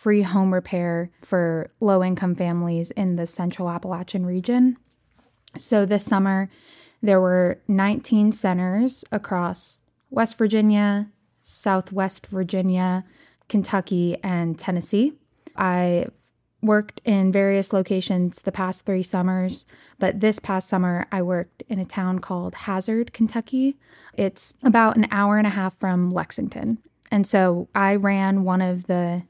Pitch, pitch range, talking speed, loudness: 190 Hz, 180-210 Hz, 130 wpm, -22 LUFS